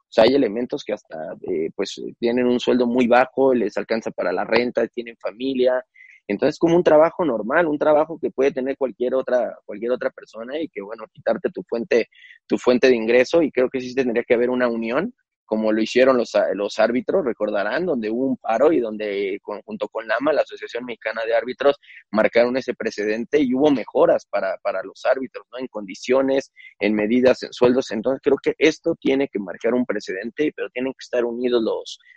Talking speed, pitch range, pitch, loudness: 200 wpm, 120-150 Hz, 130 Hz, -21 LUFS